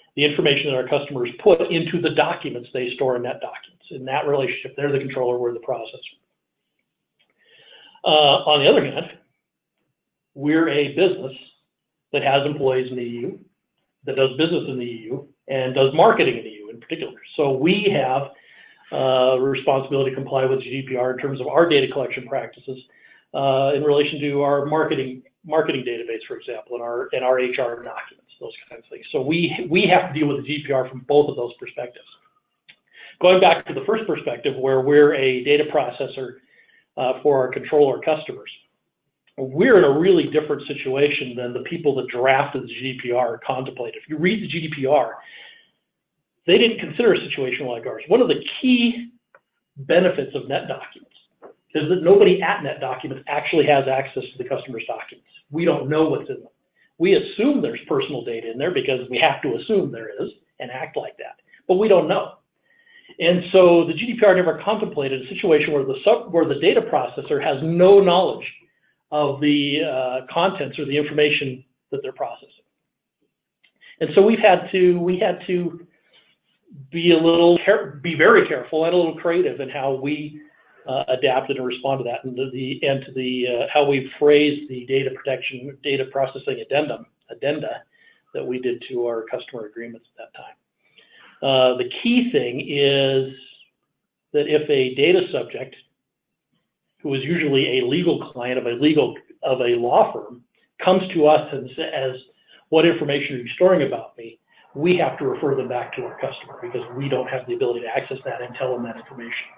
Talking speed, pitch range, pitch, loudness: 180 wpm, 130-180 Hz, 145 Hz, -20 LUFS